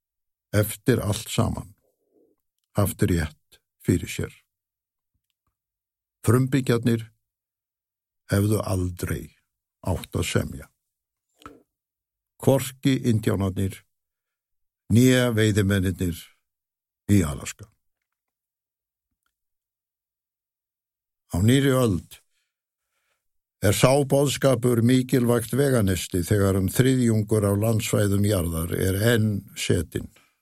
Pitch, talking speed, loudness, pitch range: 105 Hz, 70 wpm, -23 LUFS, 95-120 Hz